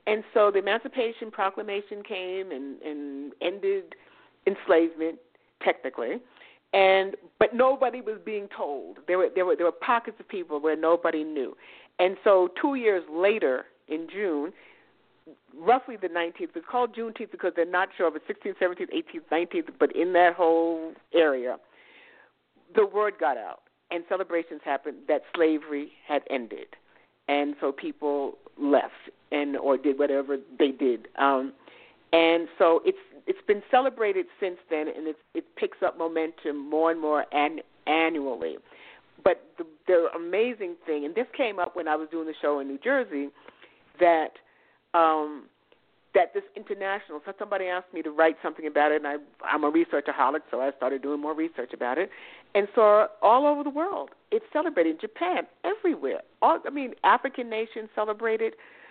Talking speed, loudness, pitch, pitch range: 165 wpm, -27 LUFS, 190 Hz, 155-260 Hz